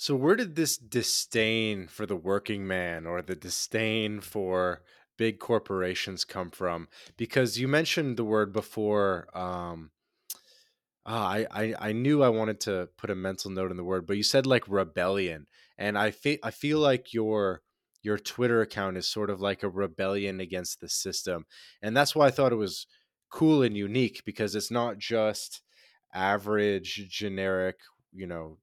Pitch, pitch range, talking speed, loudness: 105 Hz, 95-115 Hz, 170 wpm, -29 LUFS